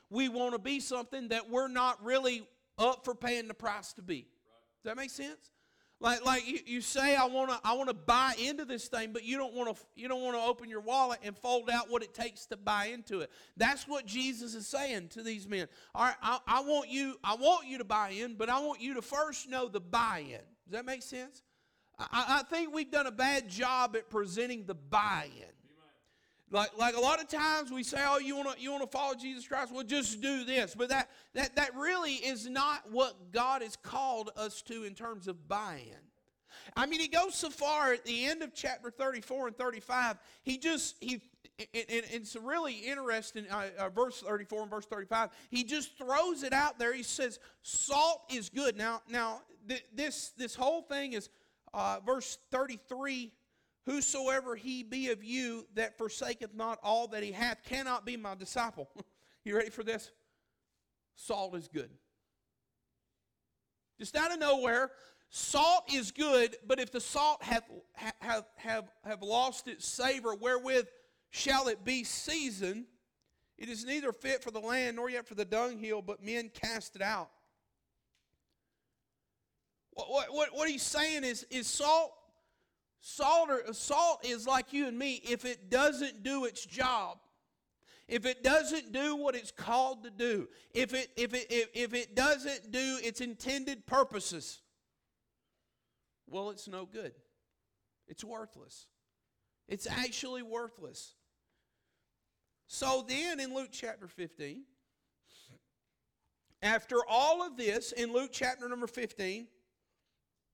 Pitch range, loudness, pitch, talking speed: 225-270 Hz, -34 LUFS, 245 Hz, 175 wpm